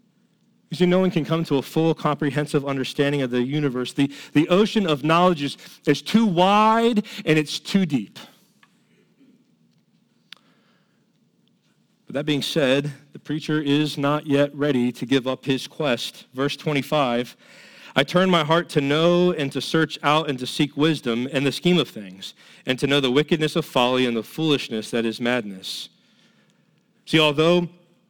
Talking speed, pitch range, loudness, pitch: 165 wpm, 135-165 Hz, -21 LUFS, 150 Hz